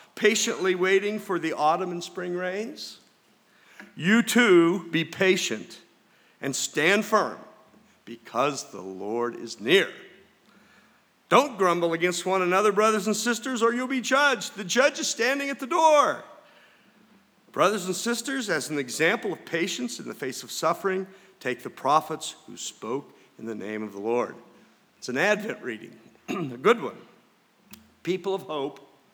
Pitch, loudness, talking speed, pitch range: 195 Hz, -25 LUFS, 150 wpm, 170-235 Hz